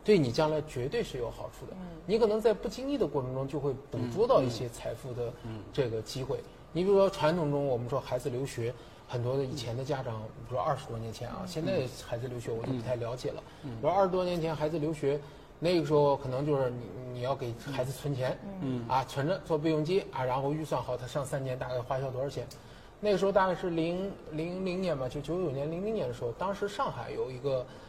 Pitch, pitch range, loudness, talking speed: 140 Hz, 125-165 Hz, -32 LUFS, 340 characters per minute